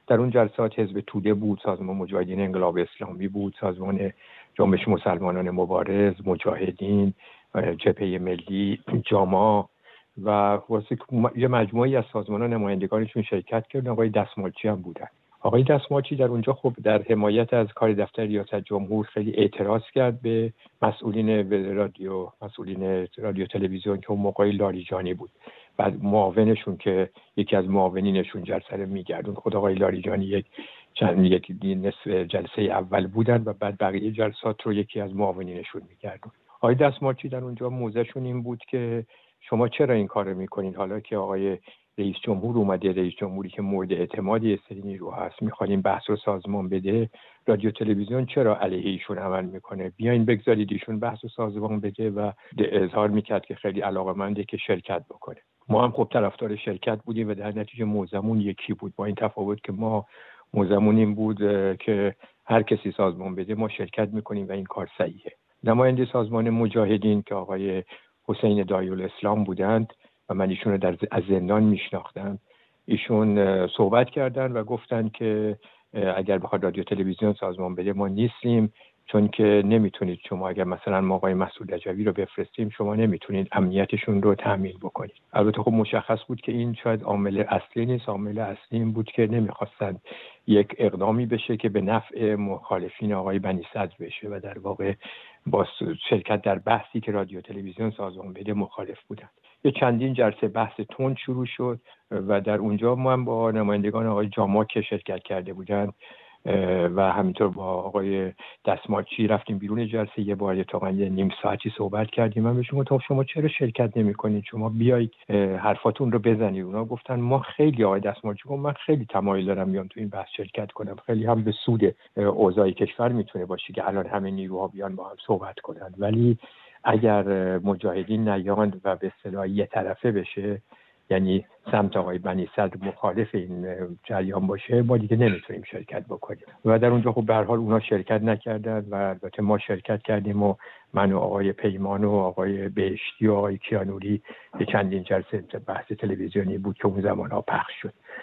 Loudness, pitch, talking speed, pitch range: -25 LUFS, 105 Hz, 165 wpm, 95-115 Hz